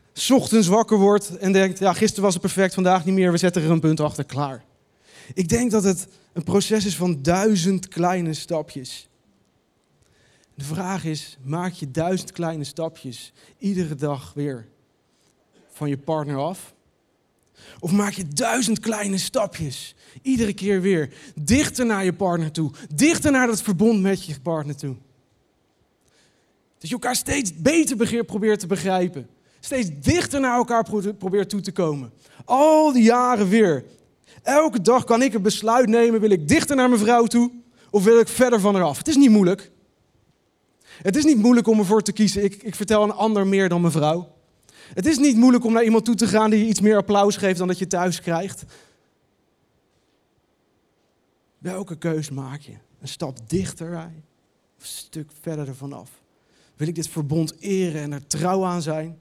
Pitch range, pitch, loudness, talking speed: 160-220 Hz, 190 Hz, -20 LUFS, 175 wpm